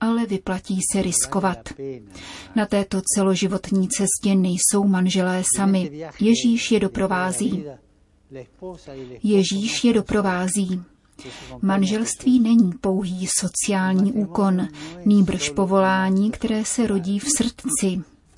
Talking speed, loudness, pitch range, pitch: 95 wpm, -21 LUFS, 185-210 Hz, 195 Hz